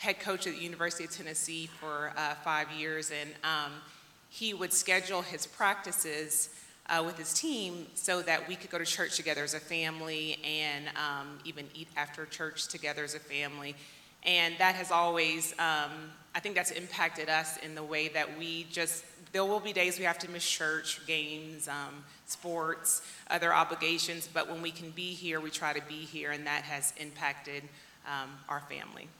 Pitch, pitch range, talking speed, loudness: 160 Hz, 150-170 Hz, 185 wpm, -33 LUFS